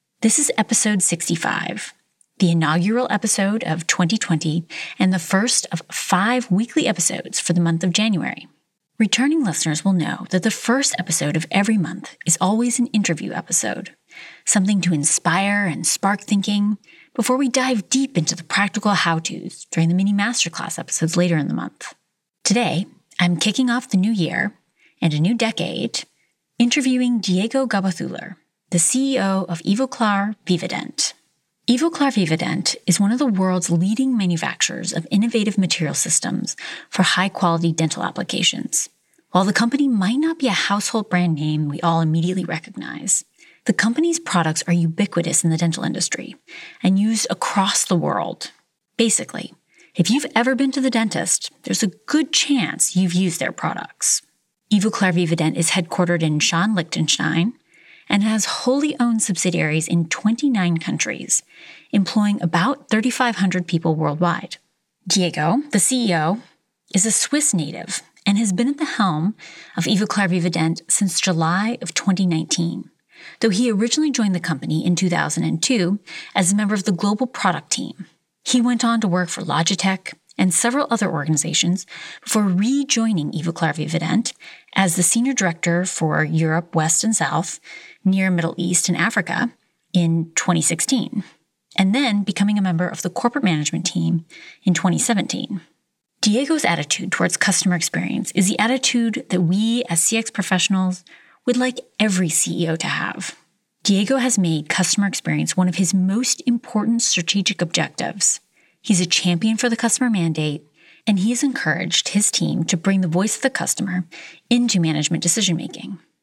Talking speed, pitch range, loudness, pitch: 150 wpm, 170-225 Hz, -19 LUFS, 195 Hz